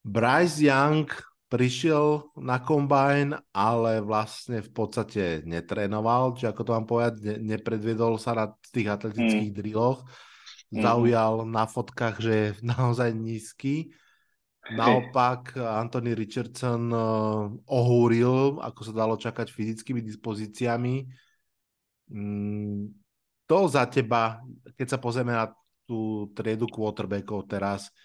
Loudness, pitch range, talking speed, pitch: -27 LUFS, 110-125 Hz, 105 wpm, 115 Hz